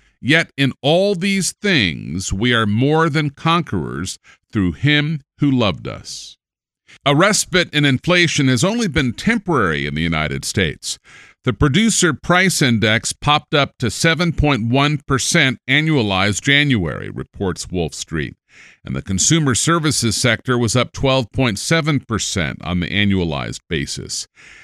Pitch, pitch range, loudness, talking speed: 135 Hz, 105-160 Hz, -17 LUFS, 140 wpm